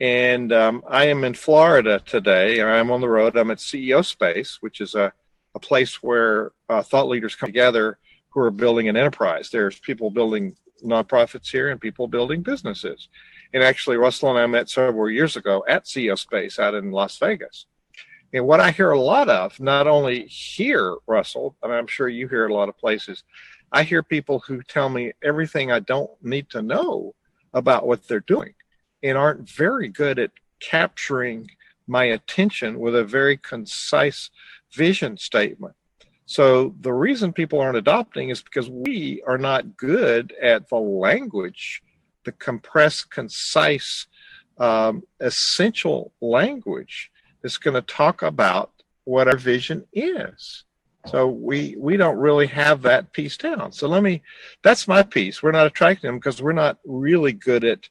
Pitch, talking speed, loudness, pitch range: 130 Hz, 170 wpm, -20 LUFS, 120-150 Hz